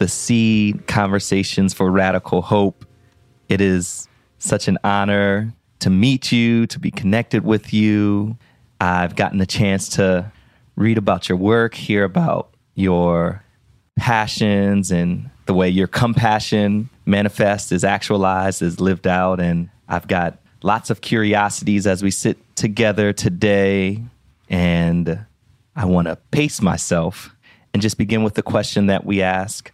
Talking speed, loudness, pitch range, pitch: 140 wpm, -18 LUFS, 95-110 Hz, 100 Hz